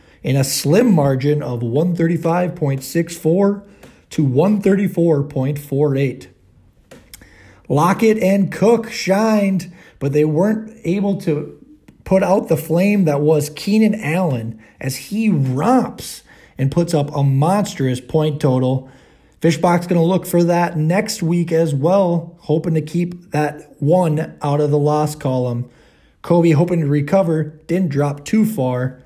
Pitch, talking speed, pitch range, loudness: 160 Hz, 130 wpm, 145-185 Hz, -17 LUFS